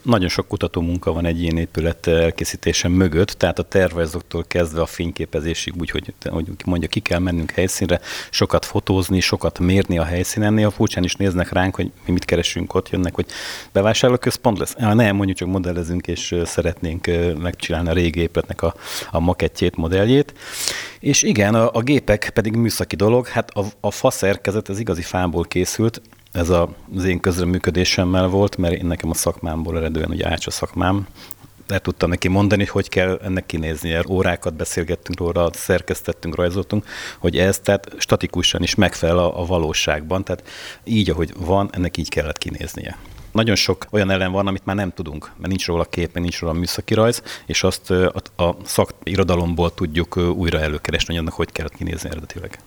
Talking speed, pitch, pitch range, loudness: 175 wpm, 90 Hz, 85-100 Hz, -20 LUFS